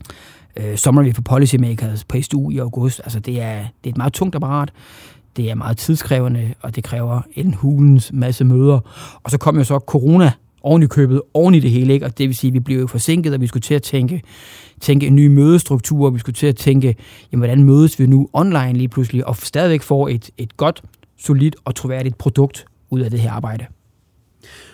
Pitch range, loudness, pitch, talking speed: 120-140 Hz, -15 LUFS, 130 Hz, 220 wpm